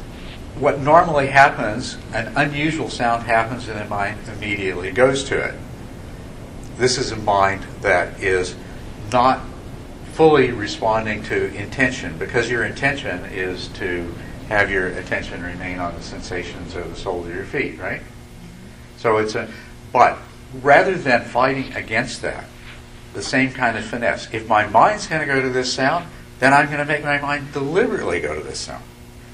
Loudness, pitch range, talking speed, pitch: -19 LUFS, 95-135 Hz, 160 wpm, 115 Hz